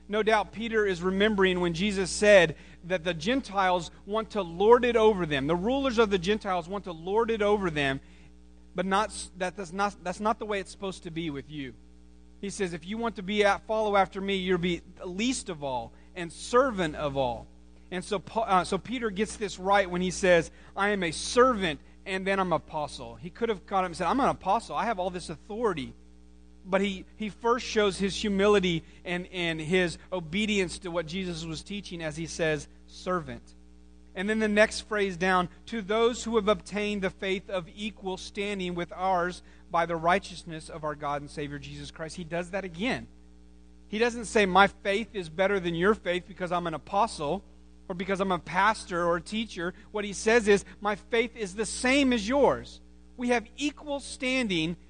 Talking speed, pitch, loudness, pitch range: 205 wpm, 185 Hz, -28 LUFS, 165-210 Hz